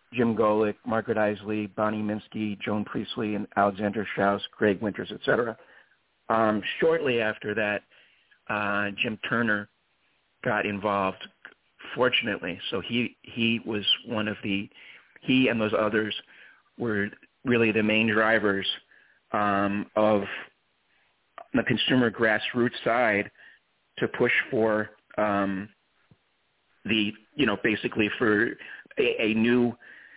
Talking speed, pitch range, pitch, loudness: 115 wpm, 105-115 Hz, 105 Hz, -26 LUFS